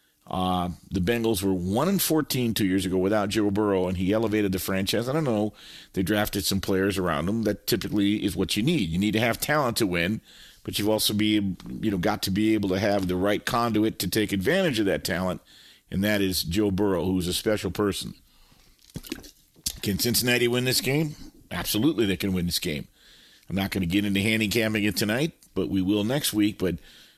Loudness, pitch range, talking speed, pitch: -25 LUFS, 95-110 Hz, 210 wpm, 105 Hz